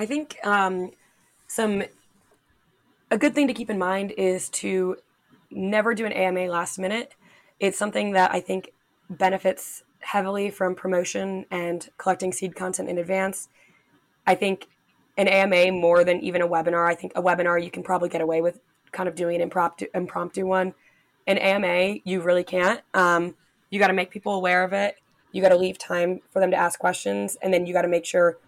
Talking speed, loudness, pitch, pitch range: 190 wpm, -24 LUFS, 185 Hz, 175-195 Hz